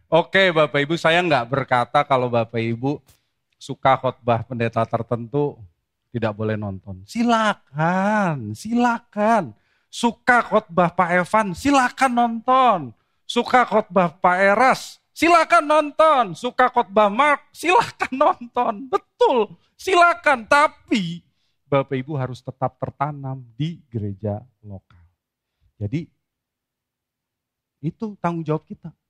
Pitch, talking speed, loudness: 170 Hz, 105 wpm, -20 LUFS